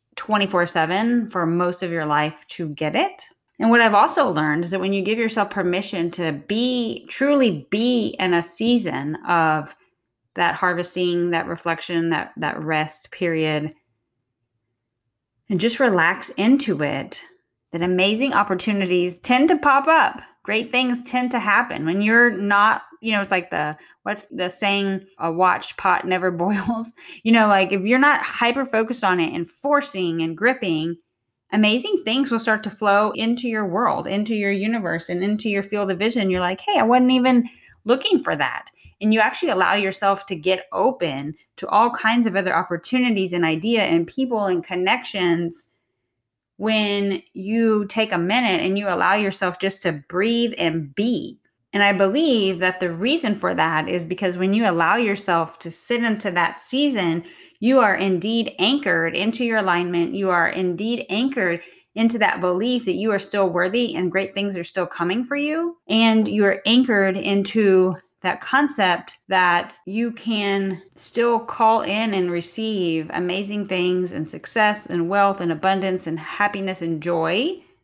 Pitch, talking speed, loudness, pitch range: 195 Hz, 170 wpm, -20 LUFS, 175-225 Hz